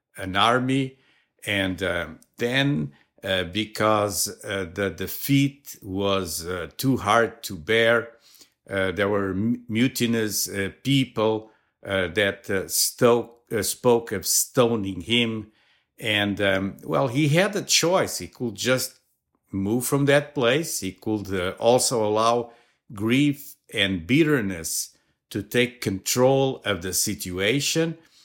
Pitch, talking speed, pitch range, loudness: 110 Hz, 125 wpm, 100-130 Hz, -23 LUFS